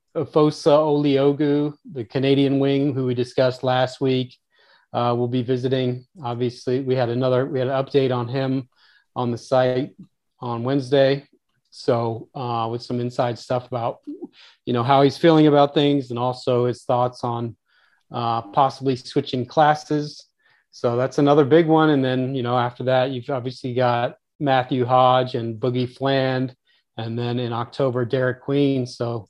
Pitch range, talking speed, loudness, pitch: 125-140 Hz, 160 wpm, -21 LUFS, 130 Hz